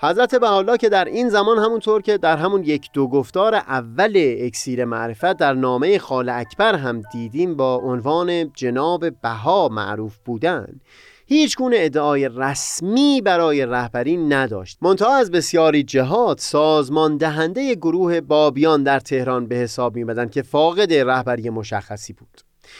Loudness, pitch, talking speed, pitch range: -18 LUFS, 150 Hz, 140 wpm, 125-175 Hz